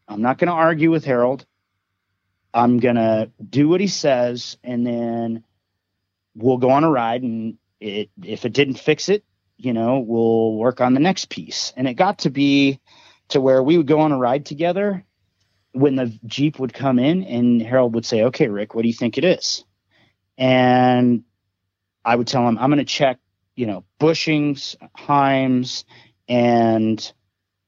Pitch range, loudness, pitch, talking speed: 110-135 Hz, -19 LUFS, 120 Hz, 180 wpm